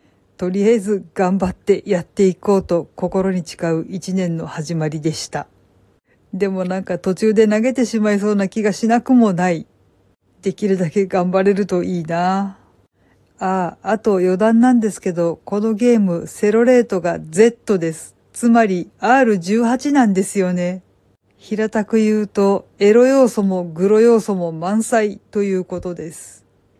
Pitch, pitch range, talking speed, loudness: 190 Hz, 175-215 Hz, 285 characters per minute, -17 LUFS